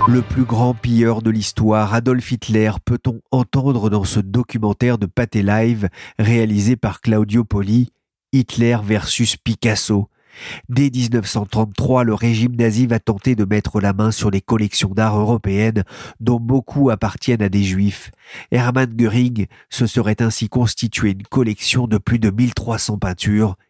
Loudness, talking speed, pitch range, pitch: -17 LUFS, 145 wpm, 105-125 Hz, 115 Hz